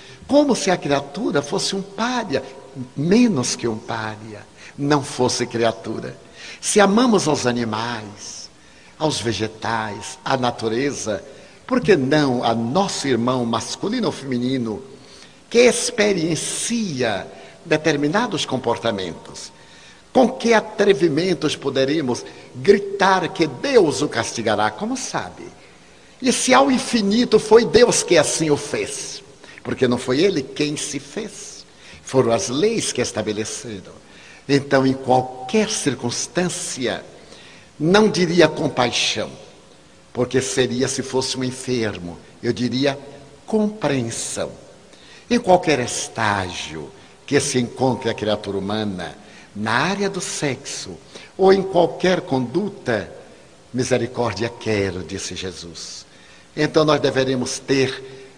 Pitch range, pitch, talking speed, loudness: 115-185 Hz, 135 Hz, 110 wpm, -20 LUFS